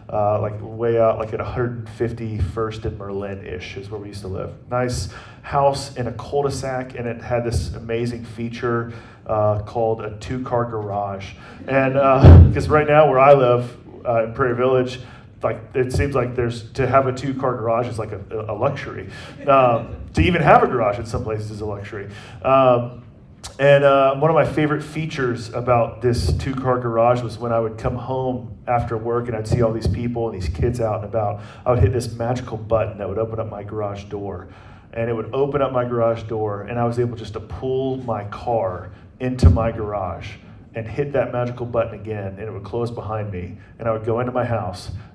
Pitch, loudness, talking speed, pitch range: 115 Hz, -20 LUFS, 210 wpm, 105-125 Hz